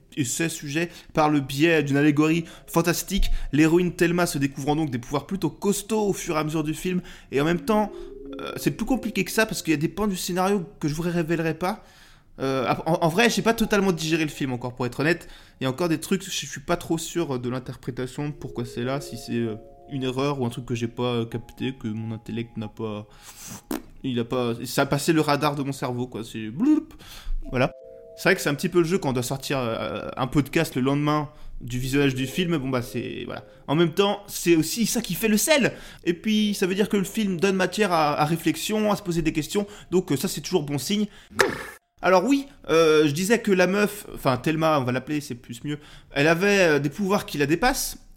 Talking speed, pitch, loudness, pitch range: 245 wpm, 160 Hz, -24 LUFS, 135-185 Hz